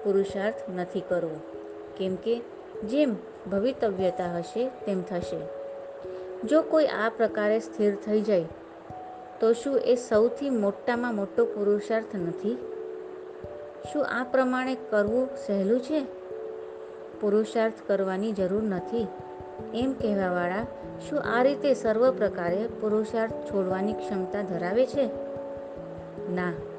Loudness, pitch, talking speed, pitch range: -28 LUFS, 215 Hz, 110 wpm, 190-245 Hz